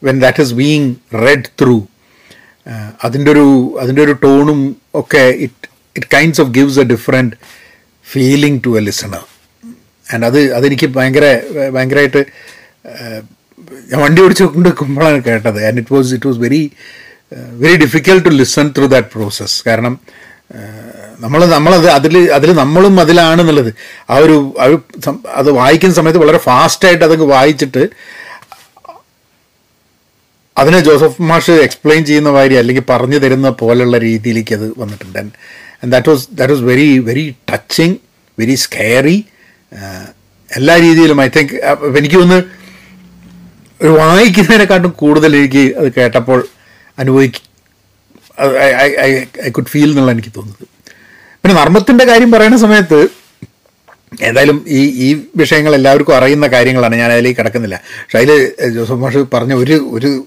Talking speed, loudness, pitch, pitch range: 120 wpm, -9 LUFS, 140 Hz, 120-155 Hz